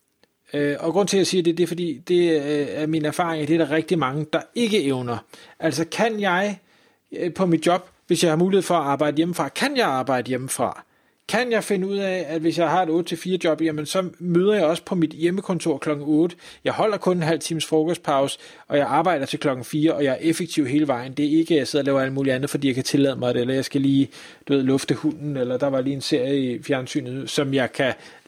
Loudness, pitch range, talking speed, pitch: -22 LUFS, 140-175 Hz, 250 wpm, 160 Hz